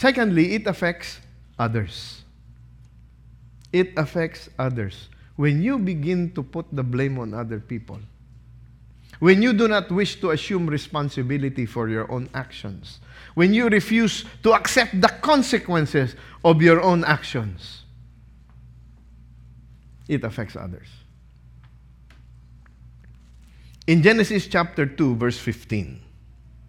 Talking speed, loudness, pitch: 110 wpm, -21 LUFS, 120 Hz